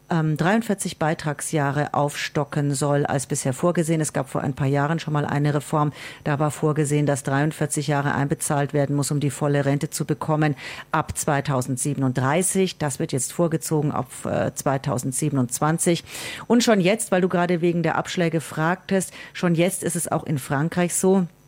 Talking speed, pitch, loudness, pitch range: 160 wpm, 150 Hz, -23 LUFS, 145-170 Hz